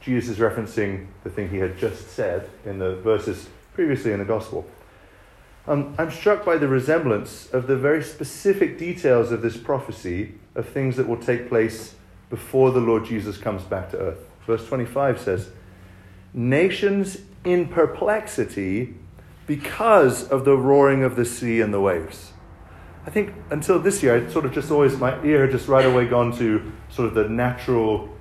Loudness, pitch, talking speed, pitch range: -22 LUFS, 120 Hz, 175 wpm, 105-140 Hz